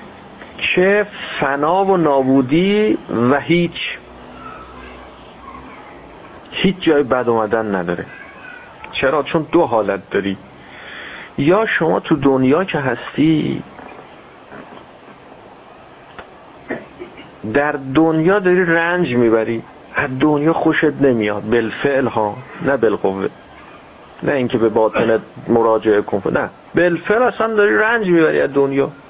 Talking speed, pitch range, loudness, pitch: 105 wpm, 115-170 Hz, -16 LUFS, 140 Hz